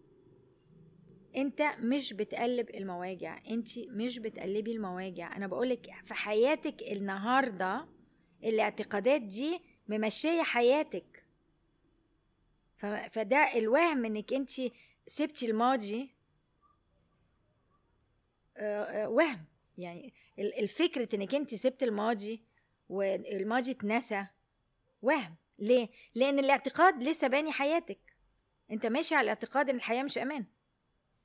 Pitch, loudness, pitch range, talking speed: 230 Hz, -32 LUFS, 205-270 Hz, 90 wpm